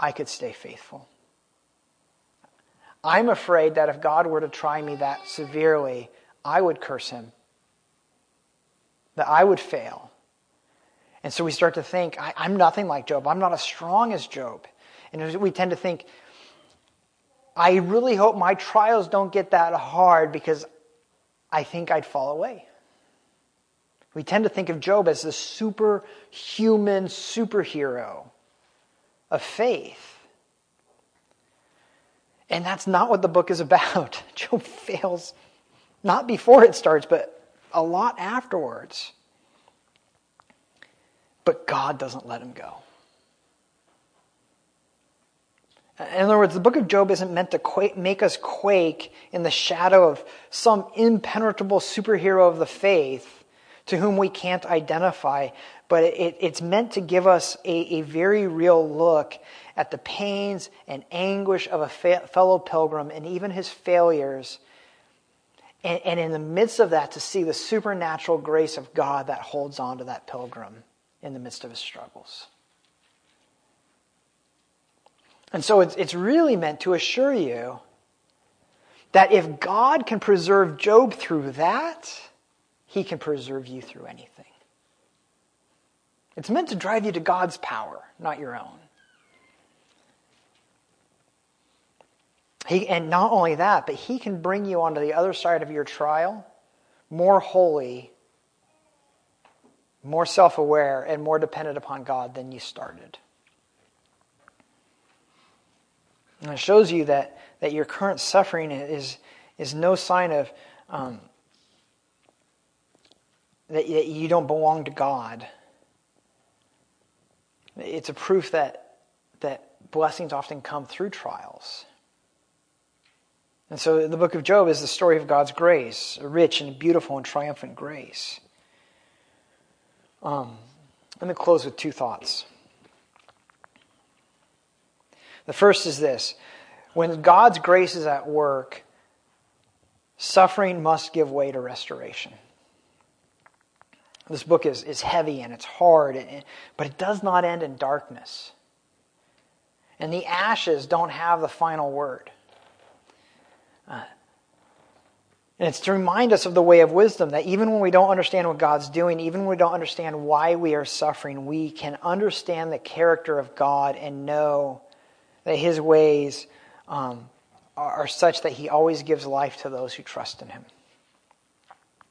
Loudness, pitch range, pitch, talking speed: -22 LUFS, 150-190 Hz, 170 Hz, 140 wpm